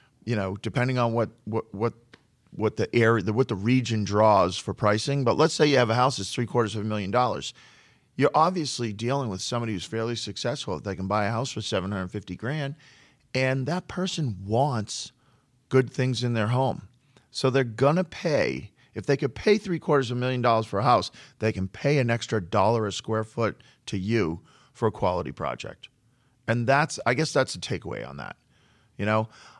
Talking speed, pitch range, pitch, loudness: 205 wpm, 110-130 Hz, 120 Hz, -26 LUFS